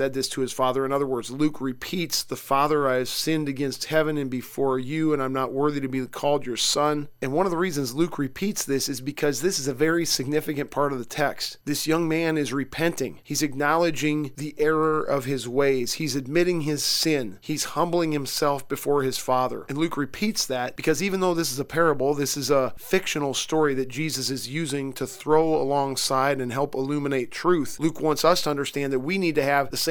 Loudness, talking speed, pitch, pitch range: -25 LUFS, 220 wpm, 145 Hz, 135-155 Hz